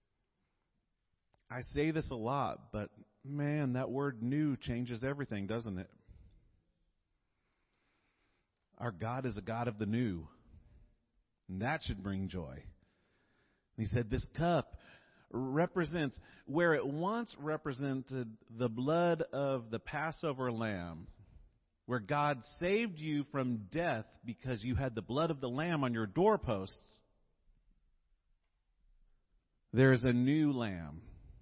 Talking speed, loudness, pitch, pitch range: 120 wpm, -36 LUFS, 120 Hz, 105-145 Hz